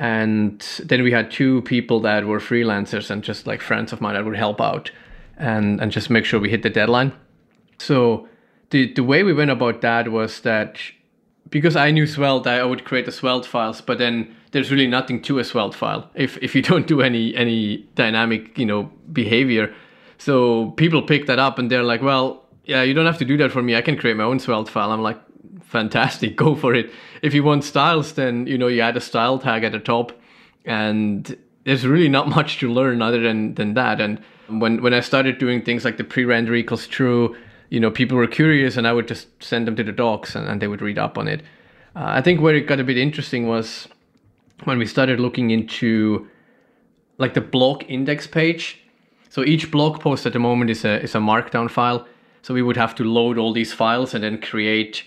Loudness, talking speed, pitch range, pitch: -19 LUFS, 220 wpm, 115-135 Hz, 120 Hz